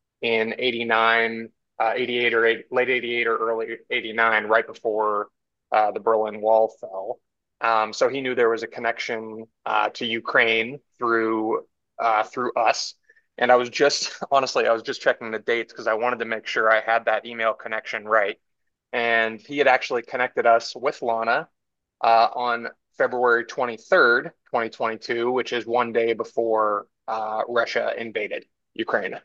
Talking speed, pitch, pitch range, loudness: 160 wpm, 115 Hz, 110-120 Hz, -23 LUFS